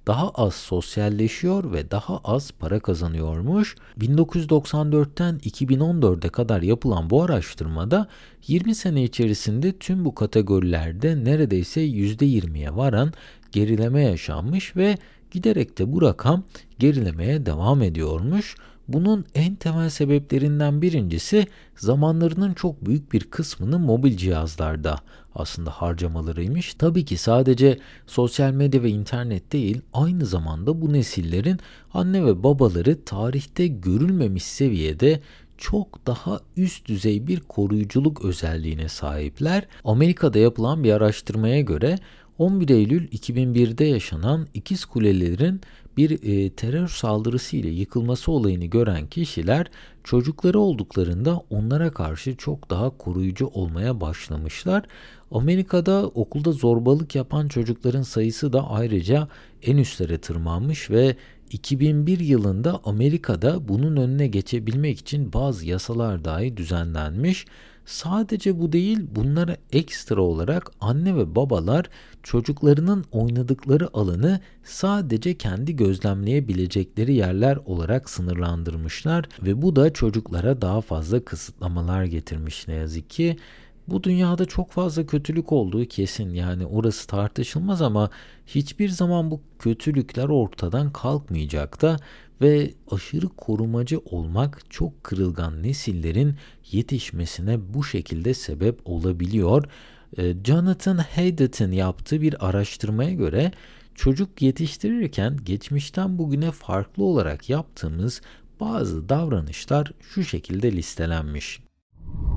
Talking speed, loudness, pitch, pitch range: 110 wpm, -23 LUFS, 125 Hz, 95-155 Hz